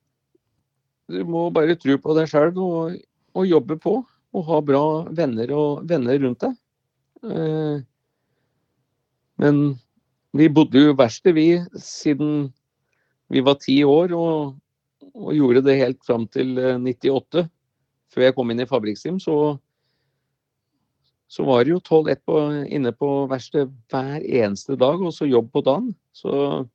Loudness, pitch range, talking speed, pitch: -20 LUFS, 130-155 Hz, 135 wpm, 140 Hz